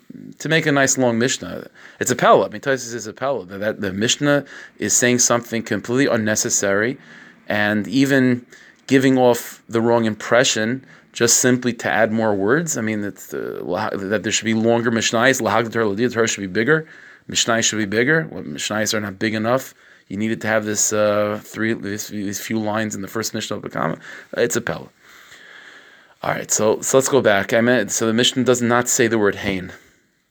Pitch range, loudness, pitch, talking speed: 105-125 Hz, -19 LUFS, 115 Hz, 190 wpm